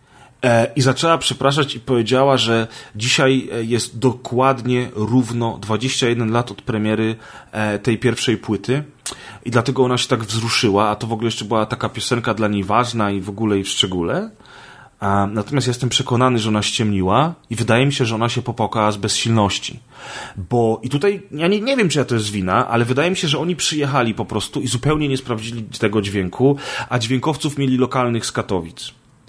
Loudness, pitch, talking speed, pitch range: -18 LUFS, 120 Hz, 180 wpm, 110-130 Hz